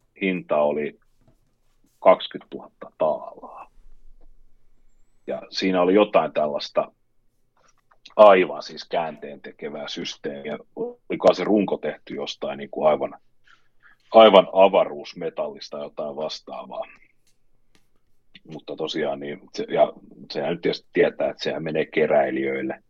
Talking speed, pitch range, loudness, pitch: 100 wpm, 70-105 Hz, -22 LUFS, 90 Hz